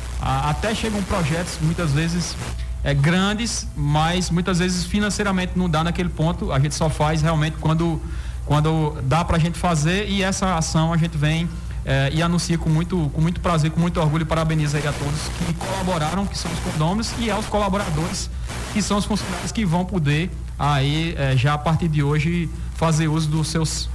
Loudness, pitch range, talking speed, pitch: -21 LUFS, 150-175 Hz, 190 wpm, 160 Hz